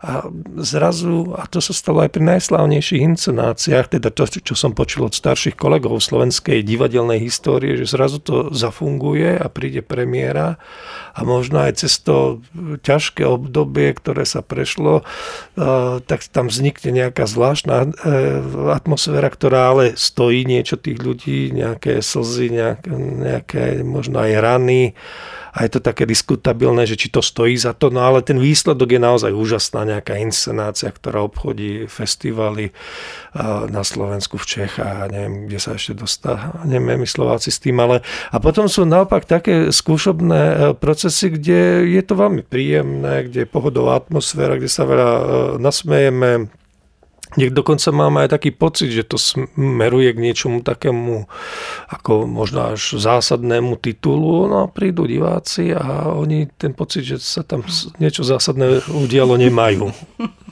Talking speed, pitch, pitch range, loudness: 145 wpm, 130 Hz, 115-155 Hz, -16 LUFS